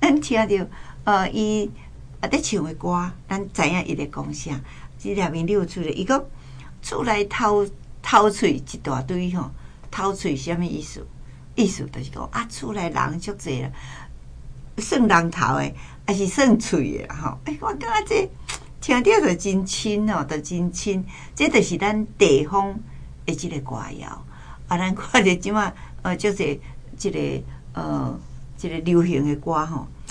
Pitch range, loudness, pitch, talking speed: 145-210 Hz, -23 LUFS, 180 Hz, 210 characters per minute